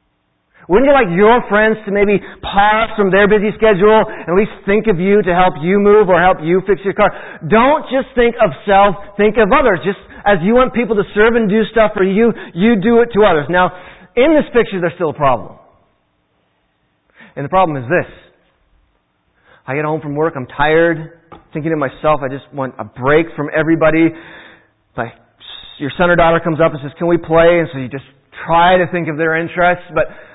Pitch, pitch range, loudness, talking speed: 180 Hz, 155-210 Hz, -13 LUFS, 210 wpm